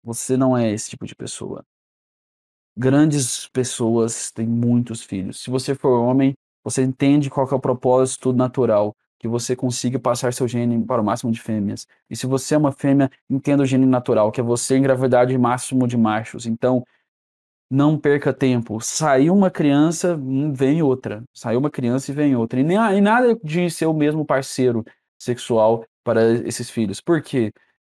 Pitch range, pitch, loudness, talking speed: 115-140 Hz, 125 Hz, -19 LUFS, 175 wpm